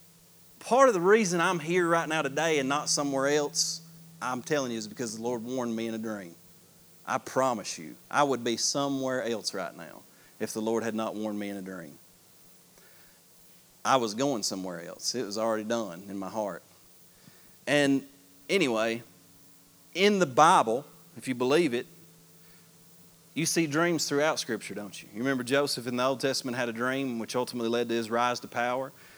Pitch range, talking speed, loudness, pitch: 110-145 Hz, 185 wpm, -28 LUFS, 125 Hz